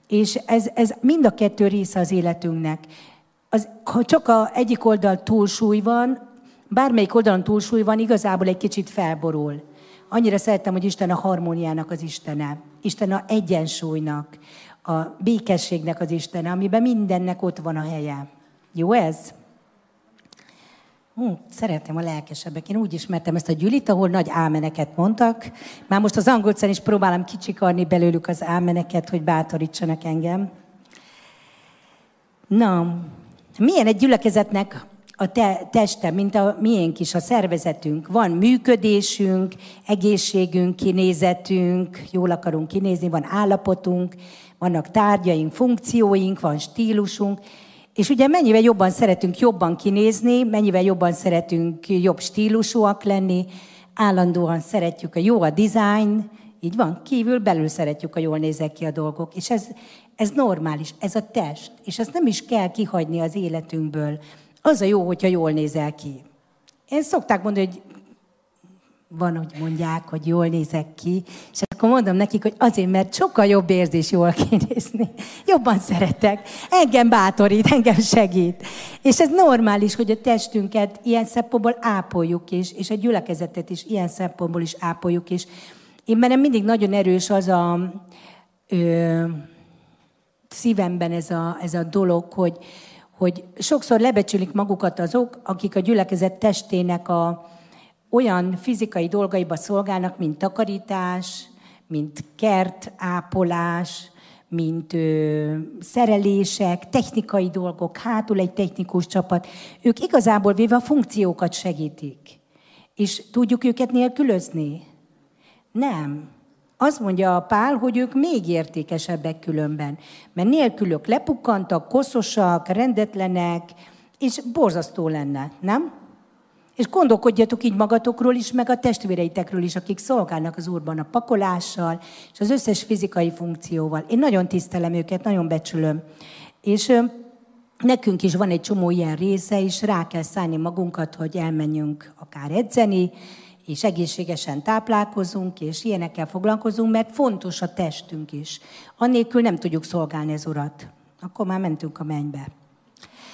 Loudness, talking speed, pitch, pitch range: -21 LUFS, 135 wpm, 190 Hz, 170-220 Hz